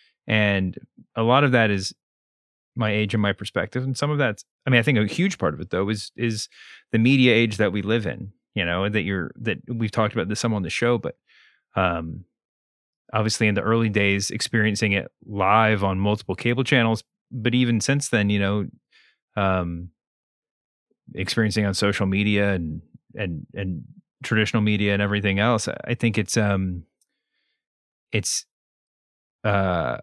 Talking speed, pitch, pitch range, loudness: 170 wpm, 105 Hz, 100-115 Hz, -23 LUFS